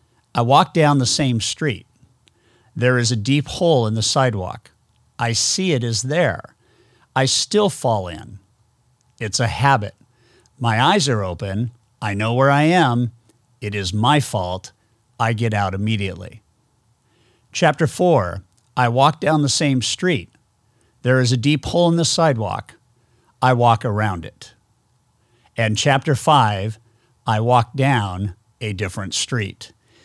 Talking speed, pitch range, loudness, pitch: 145 wpm, 110-130 Hz, -19 LUFS, 120 Hz